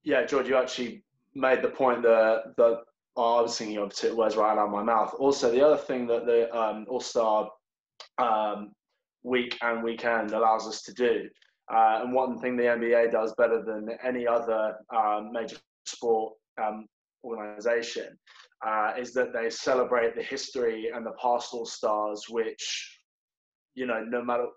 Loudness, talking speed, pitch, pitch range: -27 LUFS, 170 wpm, 115 Hz, 110-125 Hz